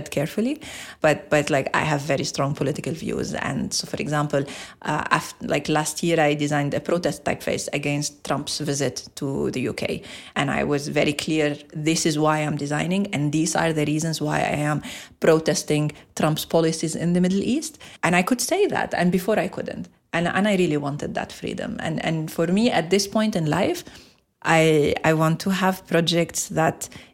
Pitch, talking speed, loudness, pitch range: 160 Hz, 190 wpm, -23 LUFS, 150-180 Hz